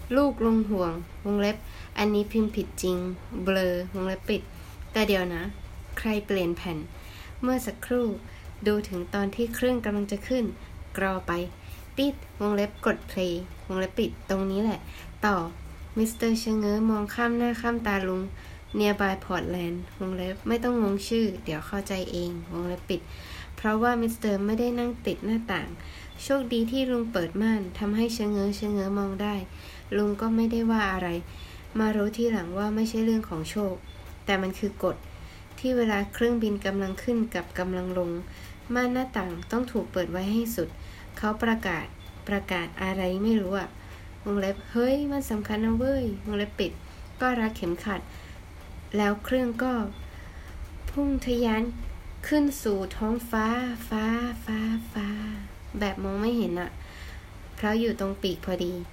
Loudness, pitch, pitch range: -28 LUFS, 205 Hz, 185-225 Hz